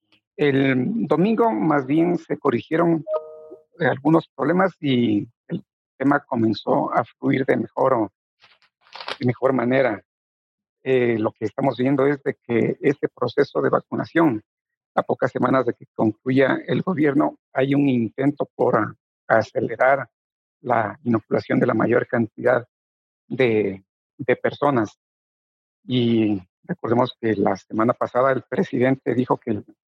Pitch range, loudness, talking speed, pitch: 110-155 Hz, -21 LUFS, 125 wpm, 130 Hz